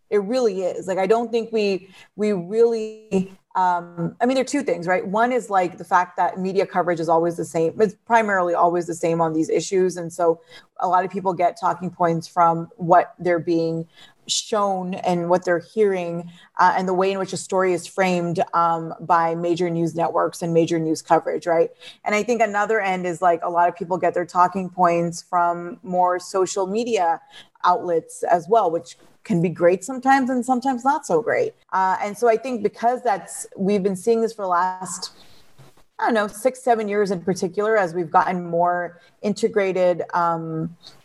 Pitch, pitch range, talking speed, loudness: 180 Hz, 170-210 Hz, 200 wpm, -21 LUFS